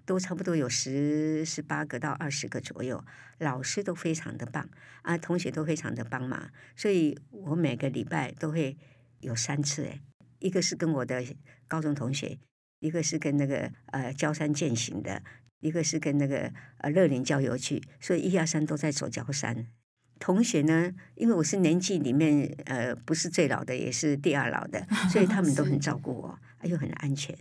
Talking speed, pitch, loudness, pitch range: 270 characters per minute, 150 Hz, -30 LUFS, 130-165 Hz